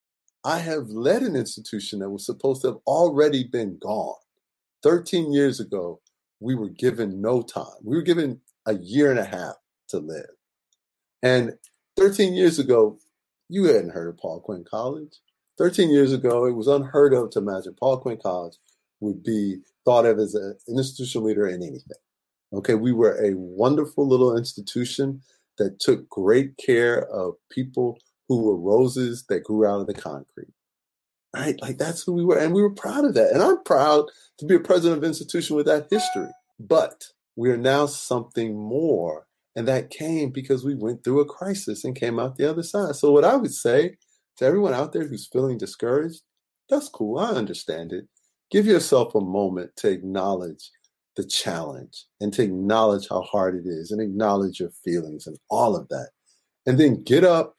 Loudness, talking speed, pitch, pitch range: -23 LUFS, 185 wpm, 130 Hz, 105-150 Hz